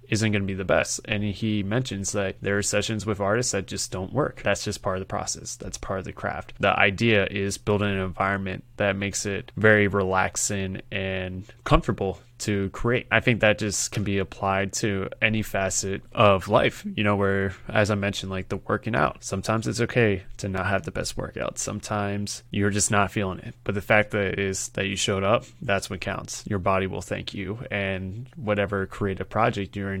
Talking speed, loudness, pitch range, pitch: 210 wpm, -25 LUFS, 95-110 Hz, 100 Hz